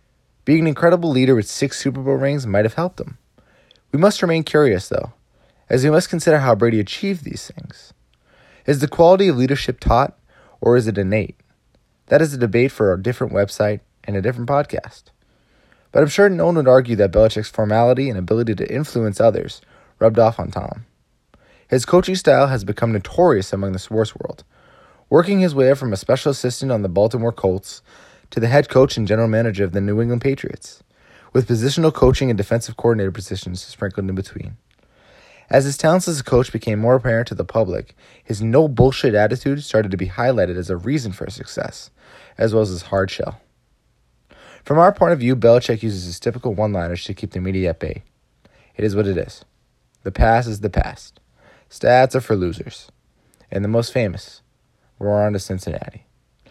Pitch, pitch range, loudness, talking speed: 115 Hz, 105-135 Hz, -18 LUFS, 195 wpm